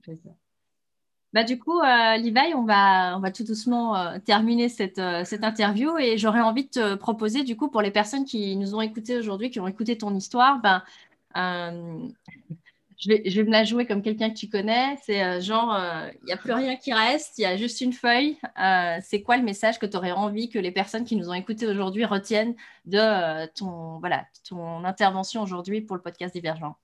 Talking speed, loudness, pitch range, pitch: 220 wpm, -24 LUFS, 190-235 Hz, 215 Hz